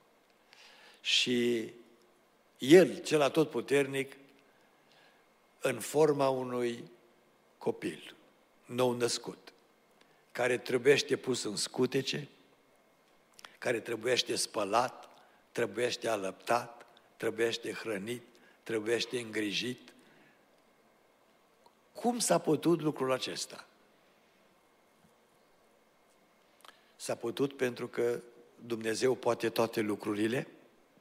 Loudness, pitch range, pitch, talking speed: -32 LUFS, 115-135 Hz, 120 Hz, 70 wpm